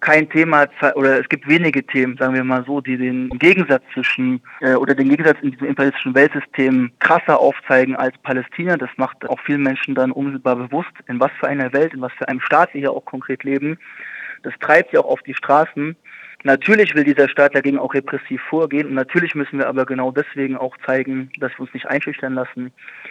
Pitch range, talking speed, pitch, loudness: 130-145 Hz, 210 wpm, 135 Hz, -17 LUFS